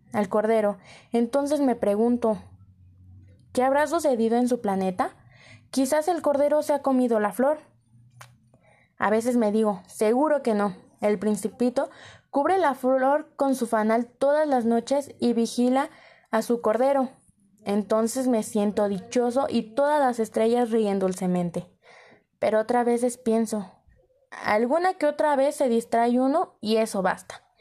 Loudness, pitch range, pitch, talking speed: -24 LUFS, 210-275 Hz, 235 Hz, 145 wpm